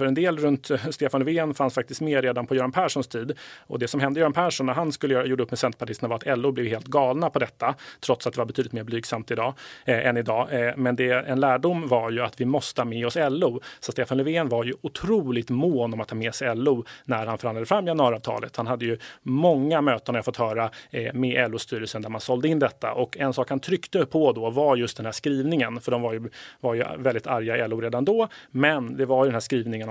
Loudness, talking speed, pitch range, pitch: -25 LUFS, 255 wpm, 120-140 Hz, 125 Hz